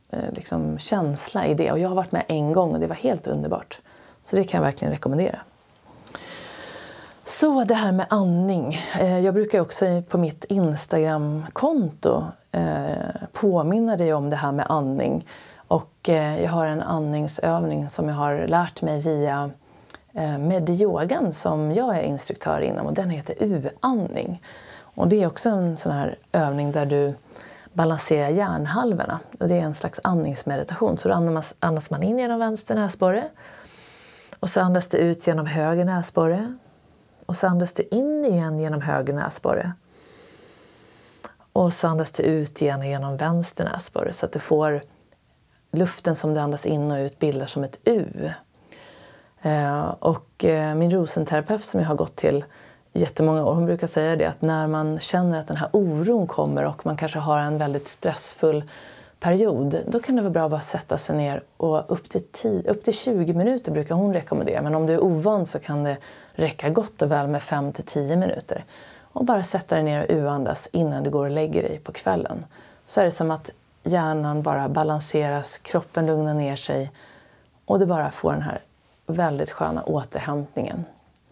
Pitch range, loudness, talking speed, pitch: 150-180 Hz, -23 LUFS, 170 wpm, 160 Hz